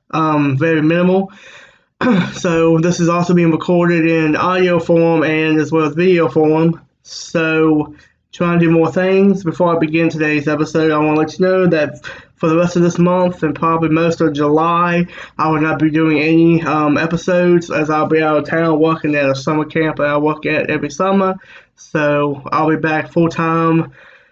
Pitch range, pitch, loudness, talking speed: 155-175 Hz, 160 Hz, -14 LUFS, 190 wpm